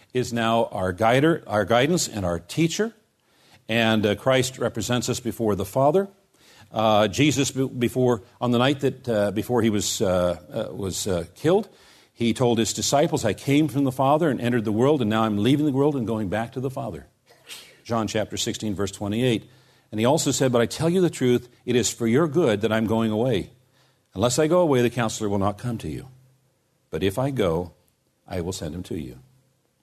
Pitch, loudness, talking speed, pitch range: 120 Hz, -23 LUFS, 205 wpm, 110-135 Hz